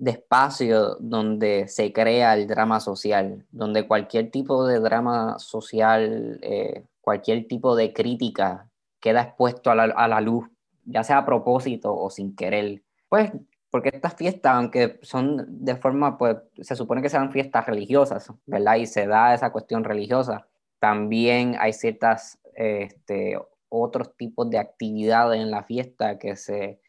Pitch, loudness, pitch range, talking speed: 115 Hz, -23 LUFS, 110-125 Hz, 155 wpm